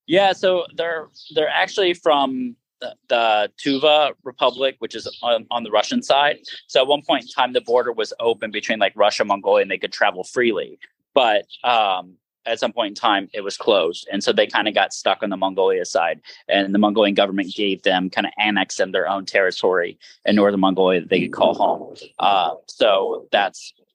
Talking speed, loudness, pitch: 205 wpm, -19 LUFS, 165 Hz